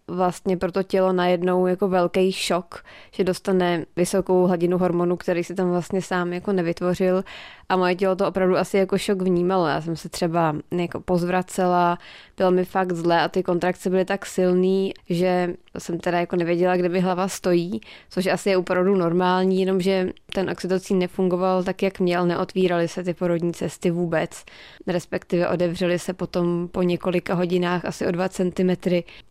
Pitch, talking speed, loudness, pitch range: 180 Hz, 170 wpm, -22 LUFS, 175-185 Hz